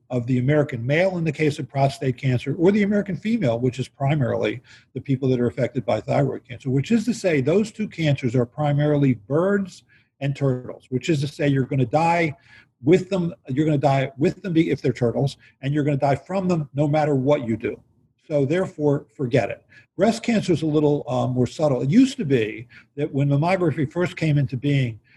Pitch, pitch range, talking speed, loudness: 145 Hz, 130-165 Hz, 215 wpm, -22 LUFS